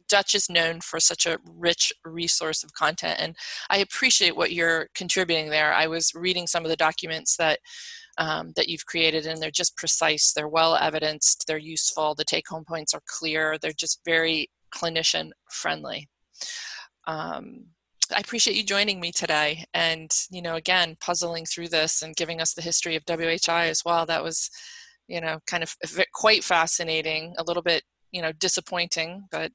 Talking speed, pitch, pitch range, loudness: 175 wpm, 165 Hz, 160-175 Hz, -24 LUFS